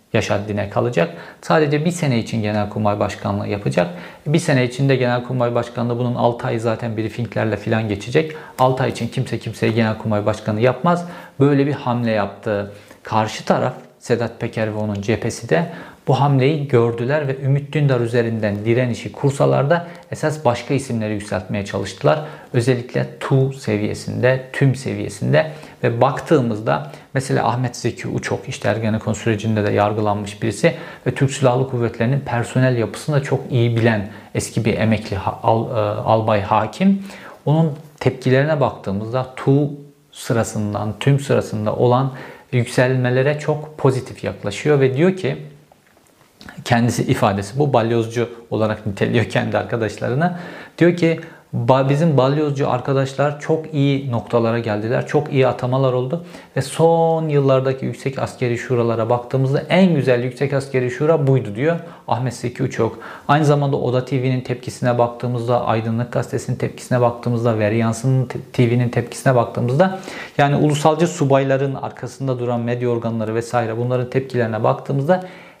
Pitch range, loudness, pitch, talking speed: 110-140 Hz, -19 LUFS, 125 Hz, 135 wpm